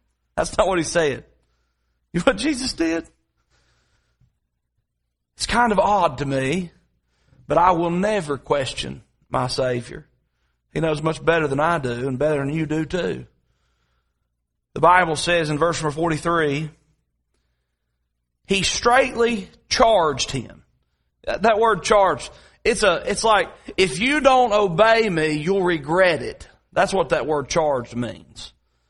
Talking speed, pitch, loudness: 140 wpm, 150 Hz, -20 LUFS